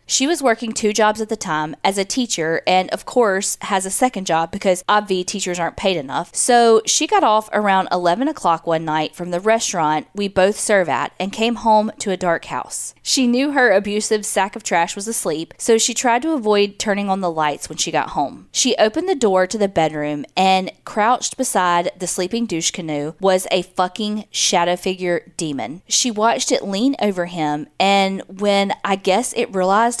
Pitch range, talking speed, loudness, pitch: 175-225 Hz, 200 wpm, -18 LUFS, 195 Hz